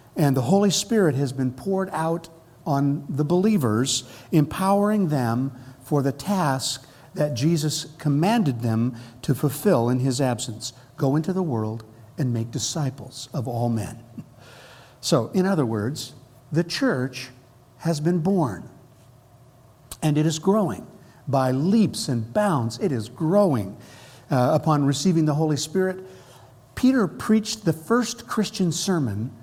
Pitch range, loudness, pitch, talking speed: 125-170 Hz, -23 LUFS, 140 Hz, 135 wpm